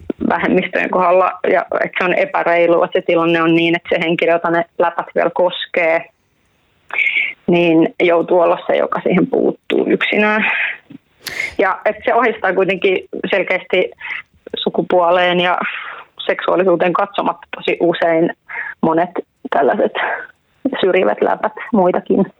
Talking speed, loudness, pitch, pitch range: 120 wpm, -15 LUFS, 180 Hz, 170-195 Hz